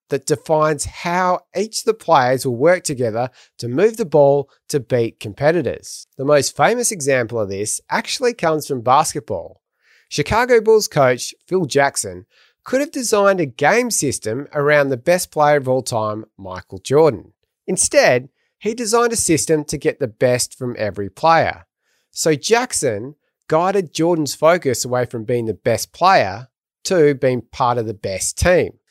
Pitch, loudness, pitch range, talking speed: 150 Hz, -17 LUFS, 125-180 Hz, 160 wpm